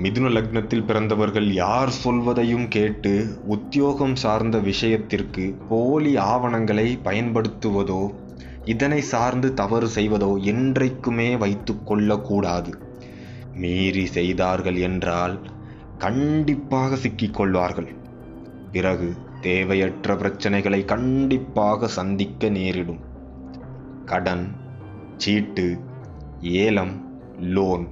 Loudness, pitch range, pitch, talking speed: -22 LUFS, 95-120 Hz, 105 Hz, 75 wpm